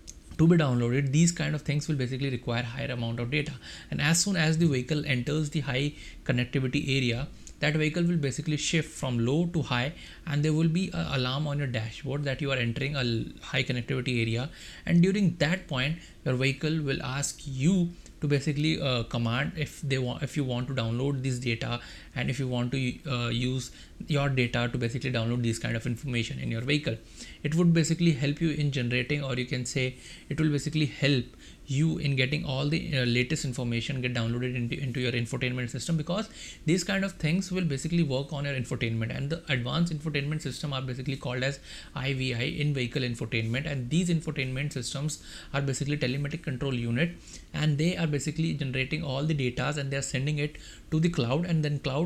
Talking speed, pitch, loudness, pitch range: 200 wpm, 140 Hz, -29 LUFS, 125-155 Hz